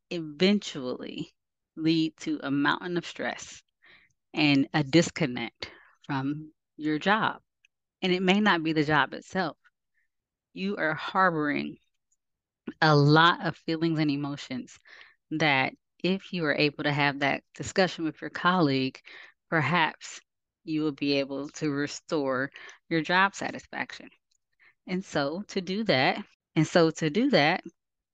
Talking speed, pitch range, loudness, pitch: 130 wpm, 145-180 Hz, -27 LUFS, 160 Hz